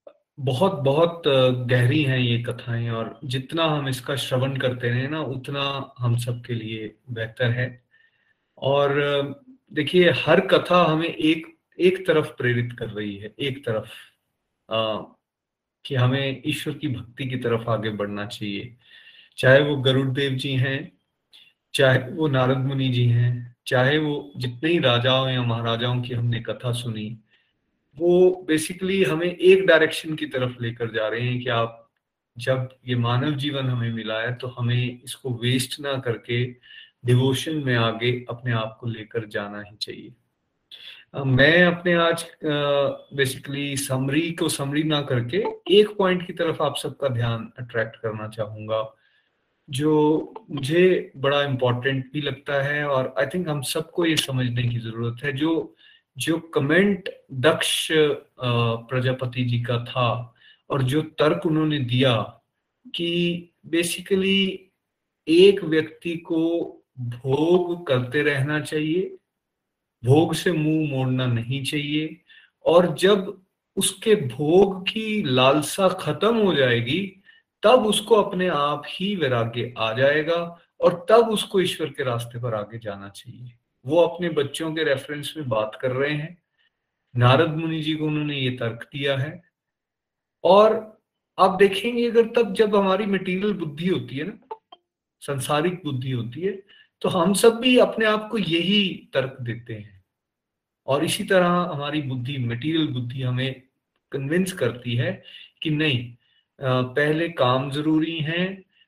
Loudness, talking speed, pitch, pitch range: -22 LUFS, 145 wpm, 140 Hz, 125-170 Hz